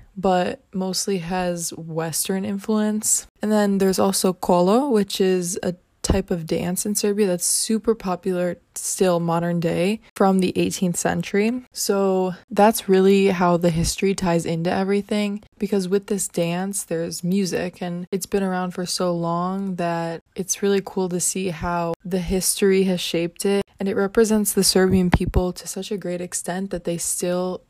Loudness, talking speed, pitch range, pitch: -22 LUFS, 165 wpm, 175-200 Hz, 185 Hz